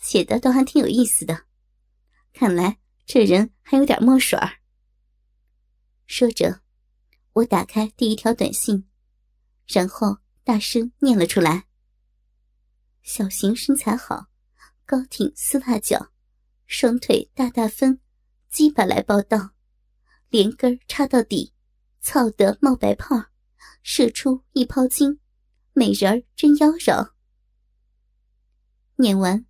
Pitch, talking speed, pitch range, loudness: 240 Hz, 160 characters per minute, 210-265 Hz, -20 LUFS